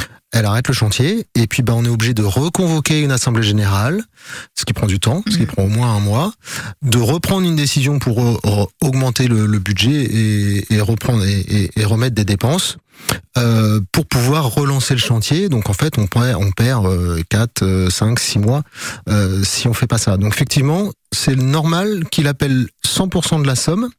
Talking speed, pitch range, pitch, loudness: 205 wpm, 105-145 Hz, 120 Hz, -16 LUFS